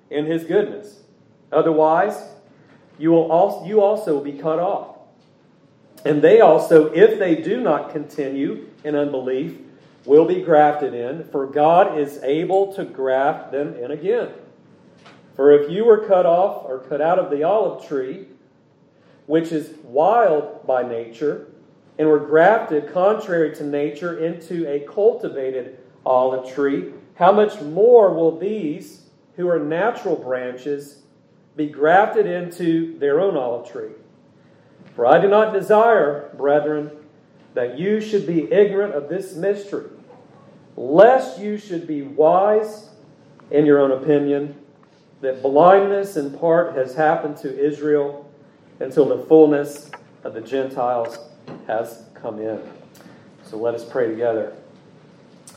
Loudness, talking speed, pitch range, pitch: -18 LUFS, 135 wpm, 145-185 Hz, 155 Hz